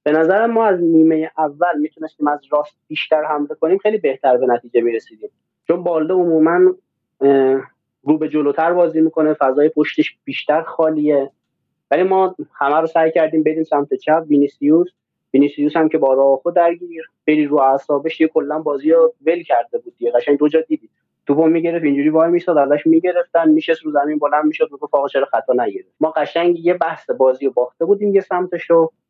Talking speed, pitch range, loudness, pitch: 170 wpm, 145-175 Hz, -16 LUFS, 160 Hz